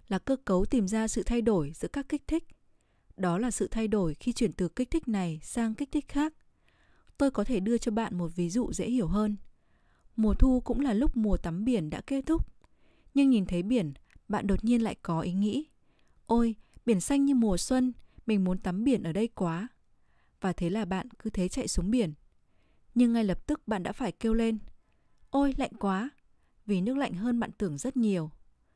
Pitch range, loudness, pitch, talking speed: 190-250 Hz, -30 LUFS, 225 Hz, 215 wpm